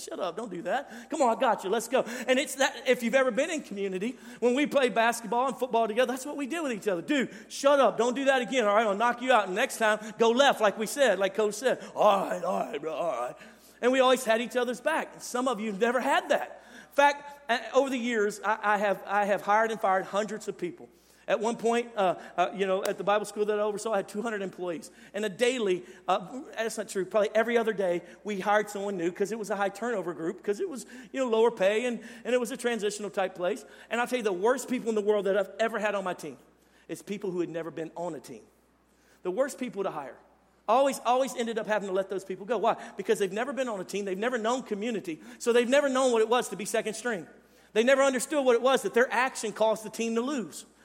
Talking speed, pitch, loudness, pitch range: 270 wpm, 225 Hz, -28 LUFS, 200-250 Hz